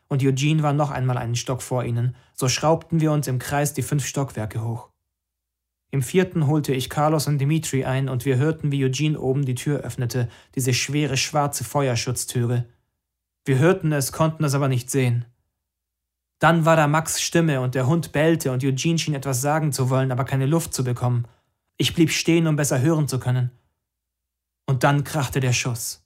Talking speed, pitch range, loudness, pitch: 190 wpm, 120-150 Hz, -22 LUFS, 135 Hz